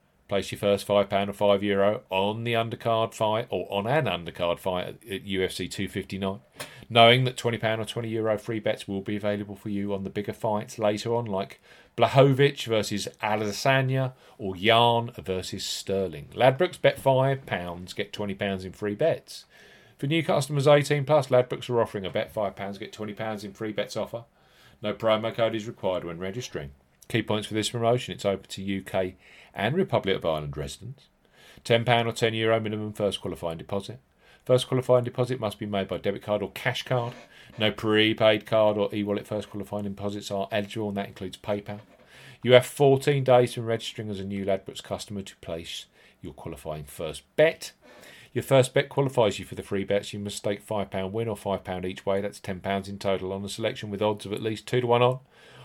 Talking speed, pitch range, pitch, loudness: 195 wpm, 100-120 Hz, 105 Hz, -26 LUFS